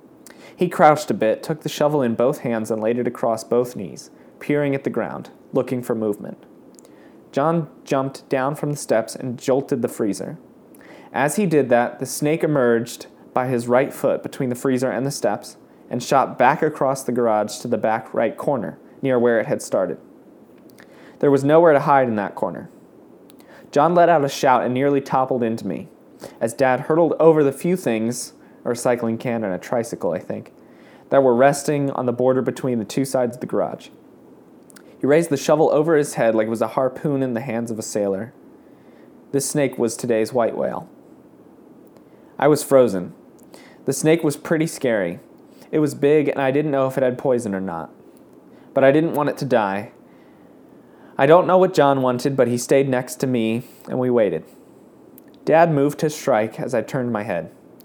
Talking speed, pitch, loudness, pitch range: 195 wpm, 135 Hz, -20 LUFS, 120-145 Hz